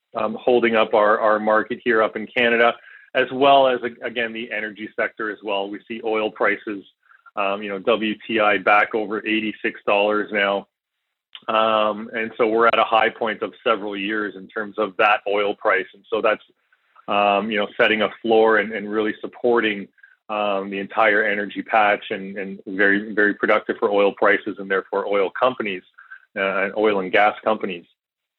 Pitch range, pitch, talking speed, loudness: 100-110 Hz, 105 Hz, 180 wpm, -20 LUFS